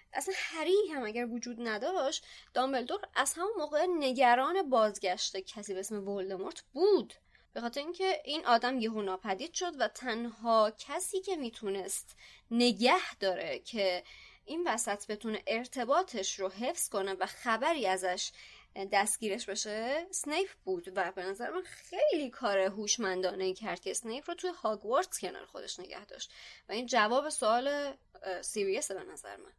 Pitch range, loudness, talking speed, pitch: 200-305 Hz, -33 LUFS, 145 wpm, 235 Hz